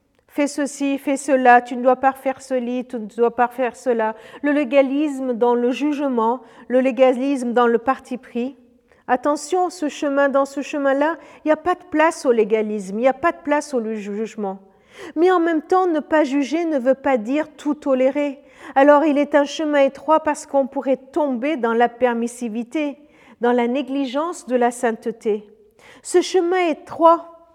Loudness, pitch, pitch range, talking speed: -20 LUFS, 270 Hz, 245-295 Hz, 185 wpm